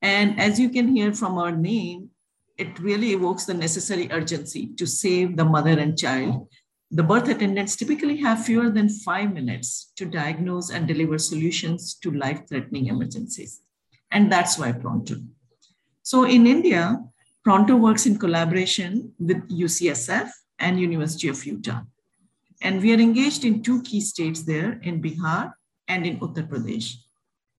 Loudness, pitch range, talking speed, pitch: -22 LUFS, 160-210 Hz, 150 wpm, 180 Hz